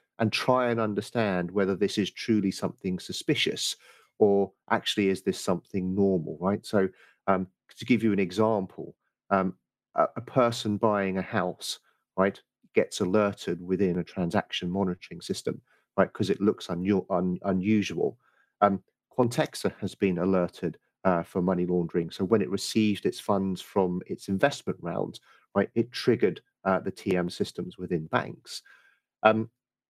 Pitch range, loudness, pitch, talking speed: 90-105 Hz, -28 LUFS, 95 Hz, 150 wpm